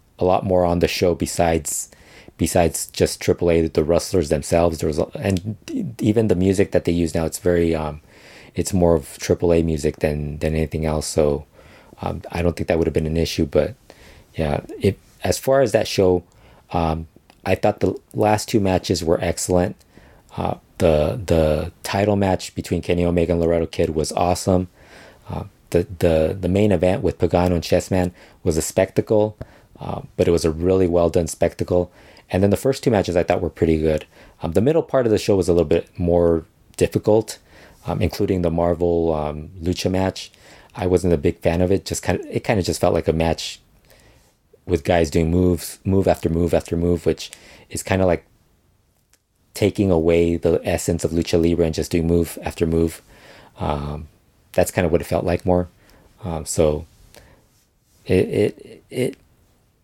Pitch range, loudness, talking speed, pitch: 80-95 Hz, -20 LUFS, 190 wpm, 85 Hz